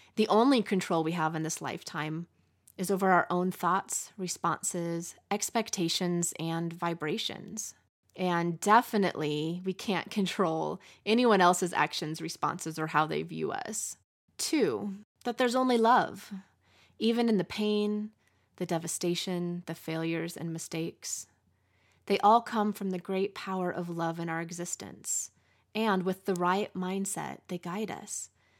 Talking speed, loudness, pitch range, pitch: 140 wpm, -30 LUFS, 165-205 Hz, 180 Hz